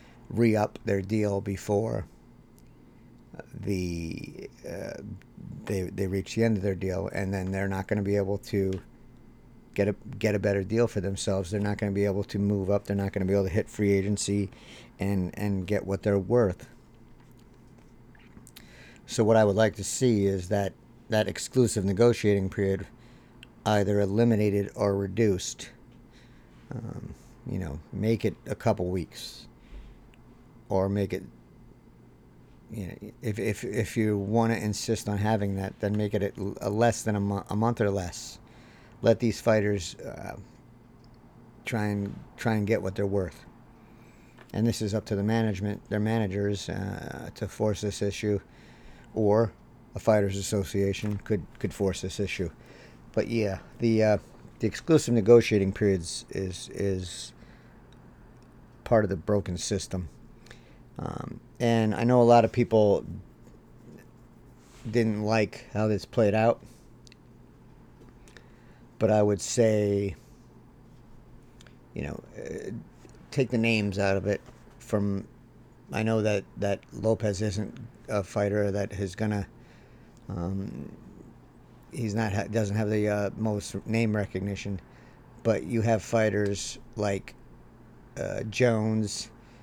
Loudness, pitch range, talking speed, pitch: -28 LUFS, 100-115 Hz, 145 wpm, 105 Hz